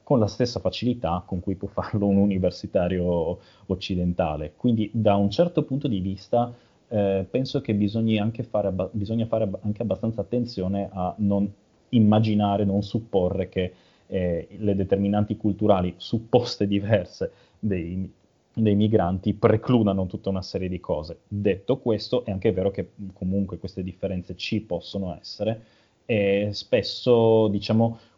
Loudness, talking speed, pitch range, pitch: -25 LUFS, 145 wpm, 95-110 Hz, 100 Hz